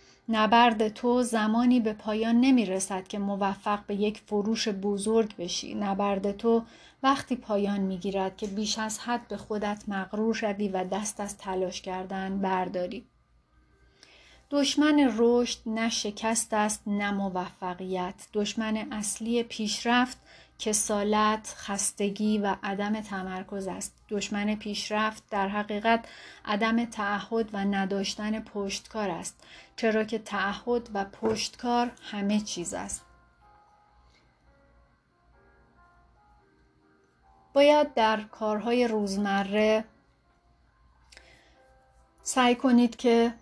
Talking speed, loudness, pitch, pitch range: 105 wpm, -28 LUFS, 210 Hz, 195-225 Hz